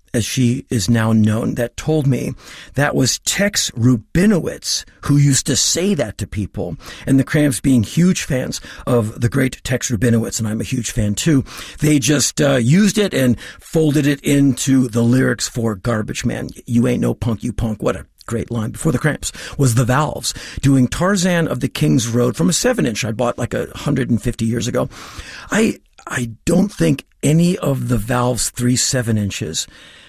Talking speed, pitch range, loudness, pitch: 190 wpm, 115-145 Hz, -17 LUFS, 125 Hz